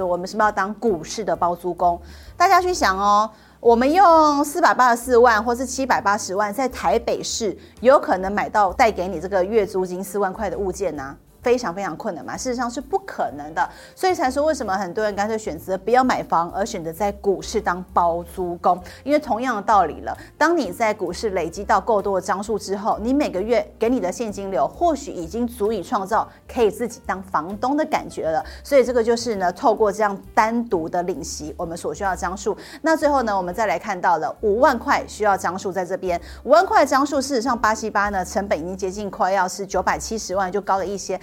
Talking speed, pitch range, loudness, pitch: 335 characters per minute, 190-255 Hz, -21 LUFS, 215 Hz